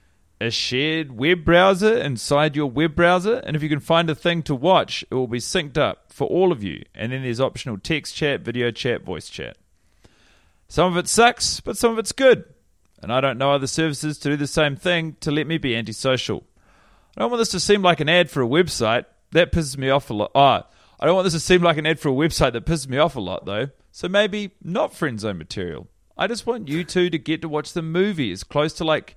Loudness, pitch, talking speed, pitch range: -21 LUFS, 155 Hz, 245 wpm, 130-175 Hz